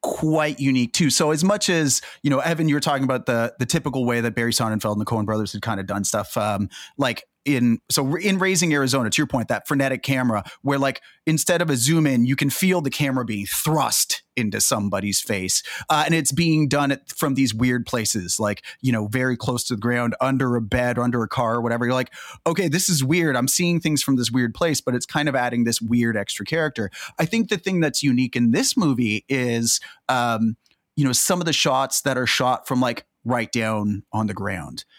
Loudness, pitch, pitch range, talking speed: -21 LUFS, 130 Hz, 115-150 Hz, 235 wpm